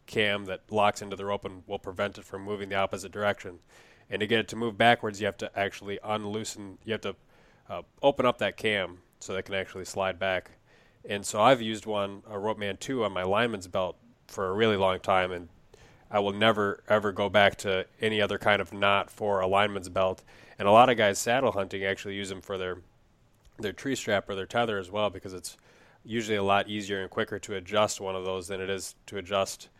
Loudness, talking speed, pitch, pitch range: -28 LUFS, 230 wpm, 100 Hz, 95-105 Hz